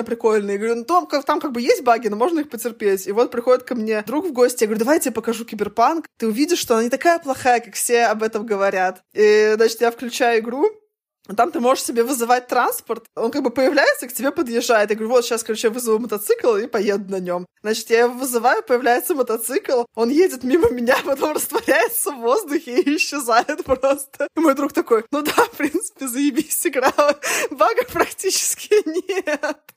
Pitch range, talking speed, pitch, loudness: 230-305 Hz, 205 wpm, 250 Hz, -19 LUFS